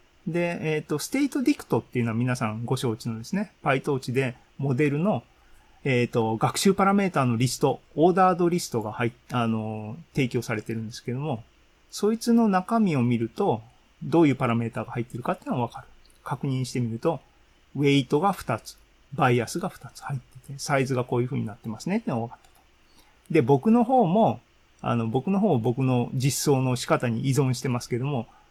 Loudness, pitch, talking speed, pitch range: -25 LUFS, 135 Hz, 395 characters per minute, 120-170 Hz